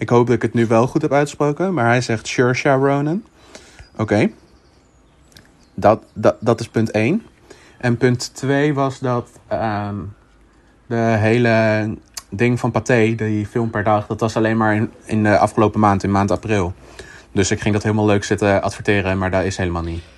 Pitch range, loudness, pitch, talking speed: 105-120 Hz, -18 LUFS, 110 Hz, 185 wpm